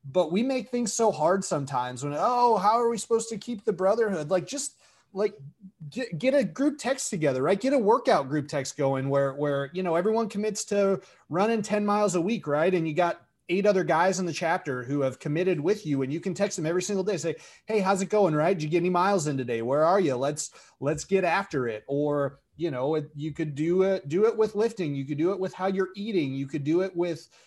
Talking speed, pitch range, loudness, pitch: 250 wpm, 150-210 Hz, -26 LUFS, 180 Hz